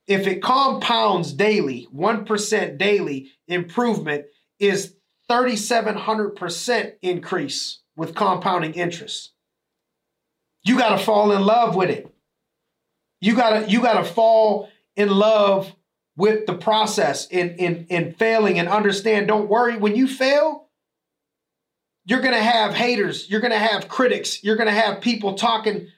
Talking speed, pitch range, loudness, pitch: 130 wpm, 190-230 Hz, -20 LUFS, 210 Hz